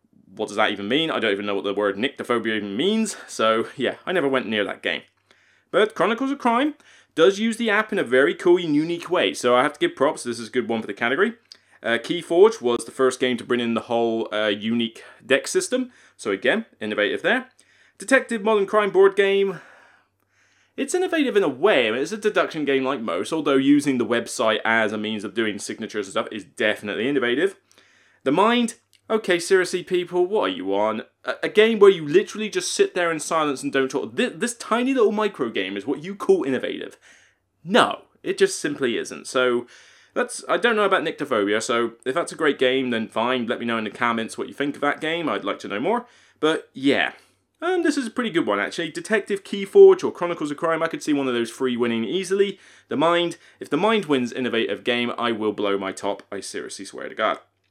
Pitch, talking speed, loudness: 155 Hz, 230 wpm, -22 LUFS